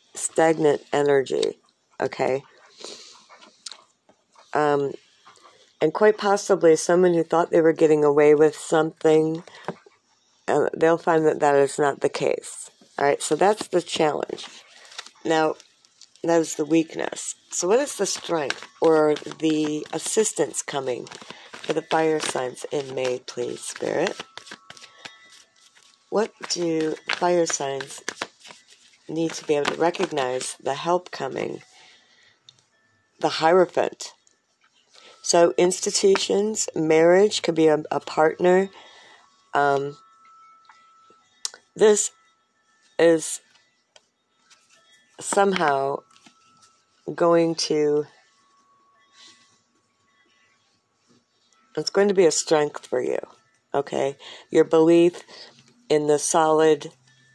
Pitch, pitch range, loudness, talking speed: 165 Hz, 150-205 Hz, -22 LUFS, 100 wpm